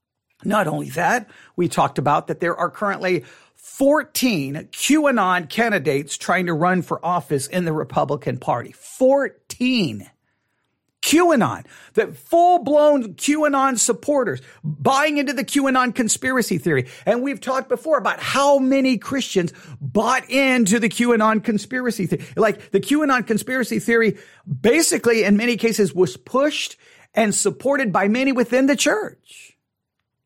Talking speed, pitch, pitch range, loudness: 135 wpm, 230 Hz, 180-270 Hz, -19 LUFS